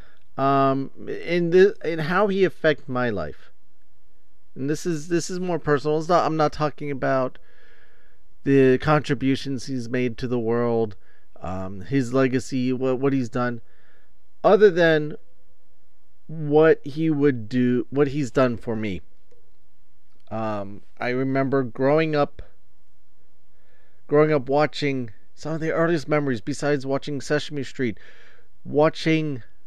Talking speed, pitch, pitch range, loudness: 130 wpm, 135 Hz, 125-150 Hz, -23 LUFS